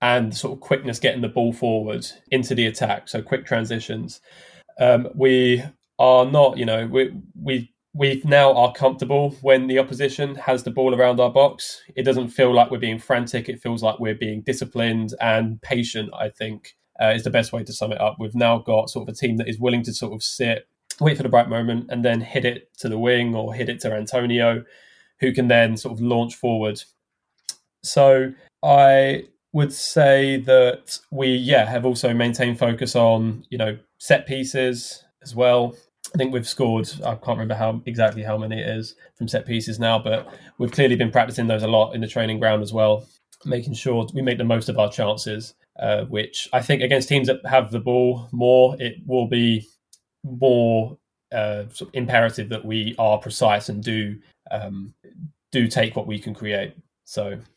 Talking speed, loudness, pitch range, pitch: 200 wpm, -20 LUFS, 110-130 Hz, 120 Hz